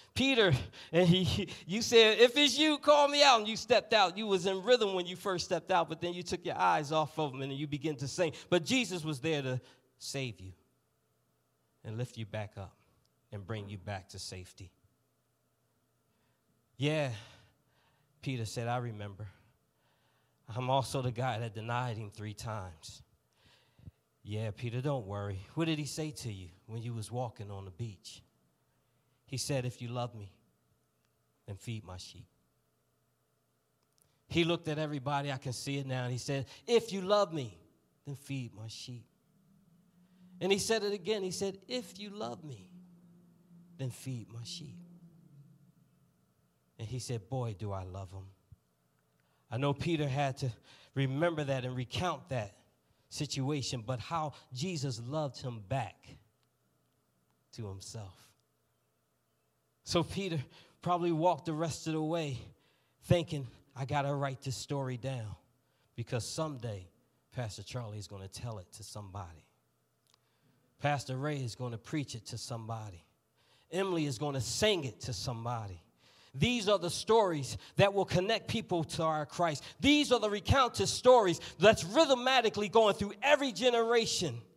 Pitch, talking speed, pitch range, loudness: 135 Hz, 160 wpm, 110-175 Hz, -33 LUFS